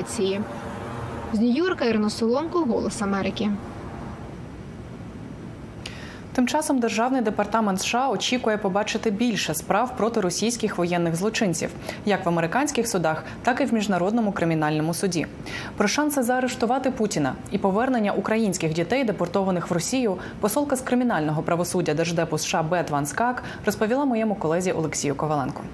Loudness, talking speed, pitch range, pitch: -24 LUFS, 125 wpm, 170-235 Hz, 205 Hz